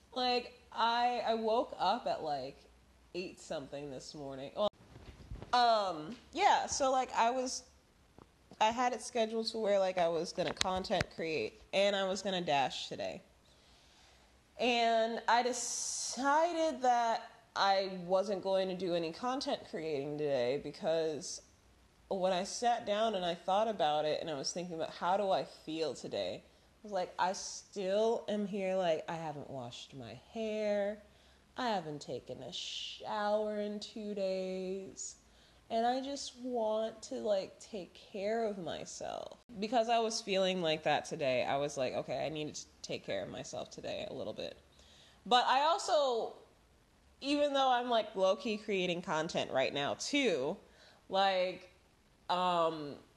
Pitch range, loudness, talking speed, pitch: 170-230 Hz, -35 LUFS, 155 wpm, 200 Hz